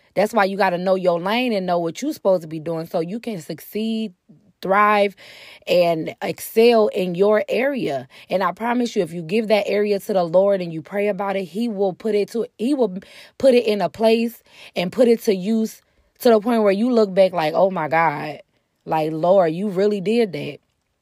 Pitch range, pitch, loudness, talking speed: 180-225 Hz, 200 Hz, -20 LUFS, 220 wpm